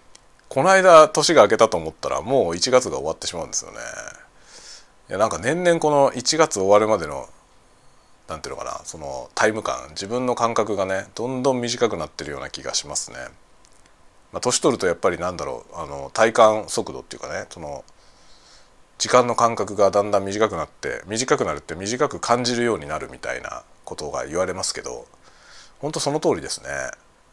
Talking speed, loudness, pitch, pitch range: 365 characters per minute, -21 LUFS, 115 Hz, 100-125 Hz